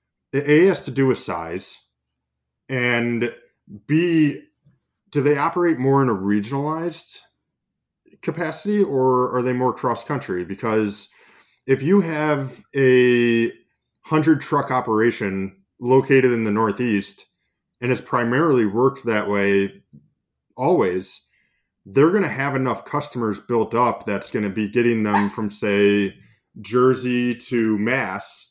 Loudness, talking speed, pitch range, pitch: -20 LUFS, 120 wpm, 105-140 Hz, 125 Hz